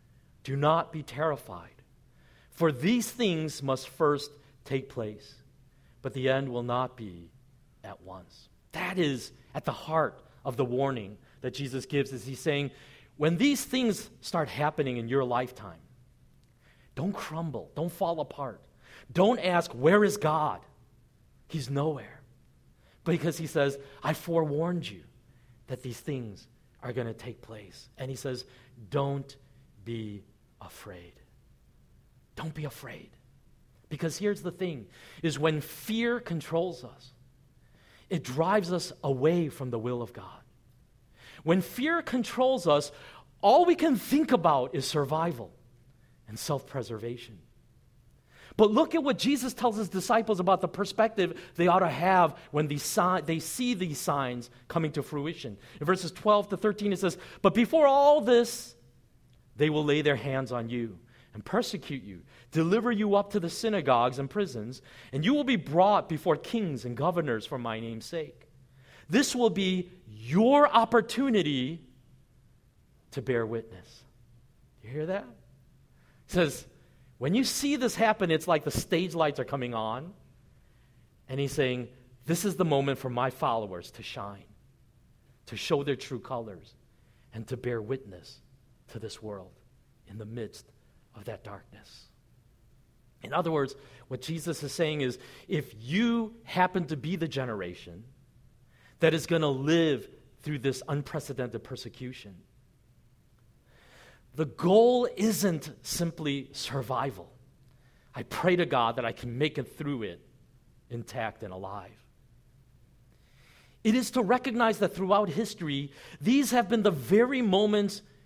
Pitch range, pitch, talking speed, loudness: 125-180 Hz, 140 Hz, 145 wpm, -29 LUFS